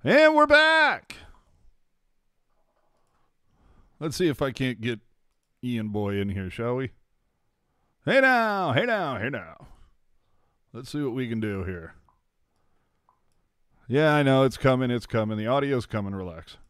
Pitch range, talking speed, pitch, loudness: 105-150 Hz, 140 wpm, 125 Hz, -24 LUFS